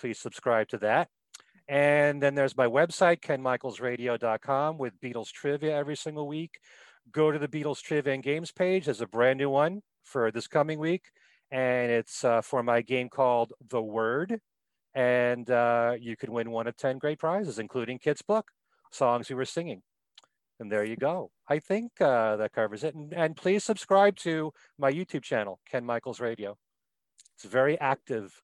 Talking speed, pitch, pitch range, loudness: 175 wpm, 135 Hz, 120-155 Hz, -29 LUFS